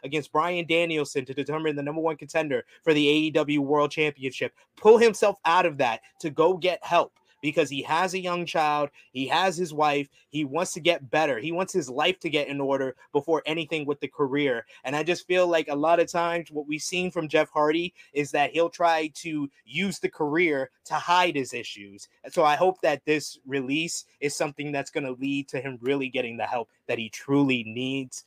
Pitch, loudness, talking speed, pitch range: 150 Hz, -26 LUFS, 210 wpm, 140-170 Hz